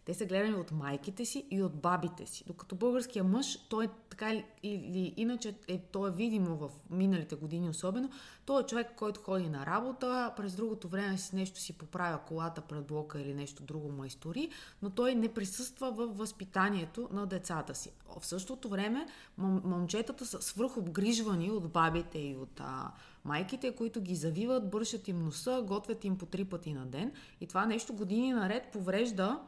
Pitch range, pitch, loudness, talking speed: 175-230 Hz, 195 Hz, -36 LUFS, 180 wpm